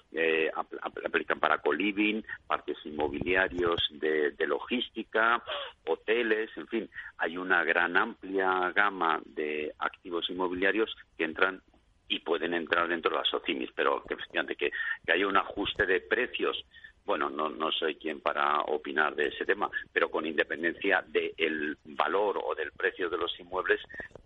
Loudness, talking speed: -30 LUFS, 155 wpm